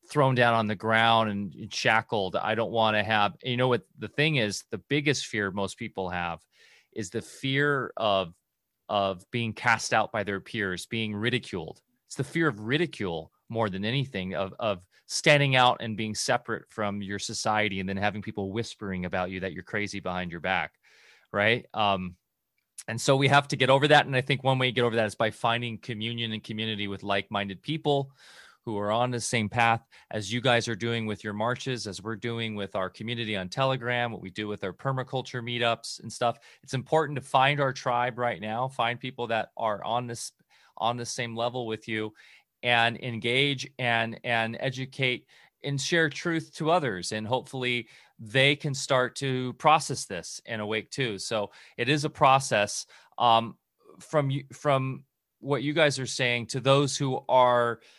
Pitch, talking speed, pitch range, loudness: 120 Hz, 190 wpm, 110-135 Hz, -27 LUFS